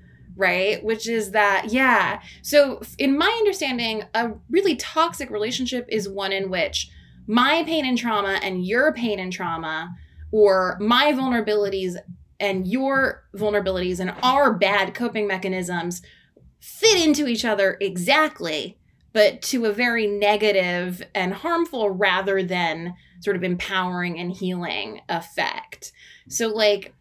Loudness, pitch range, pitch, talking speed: -22 LUFS, 185-250 Hz, 210 Hz, 130 wpm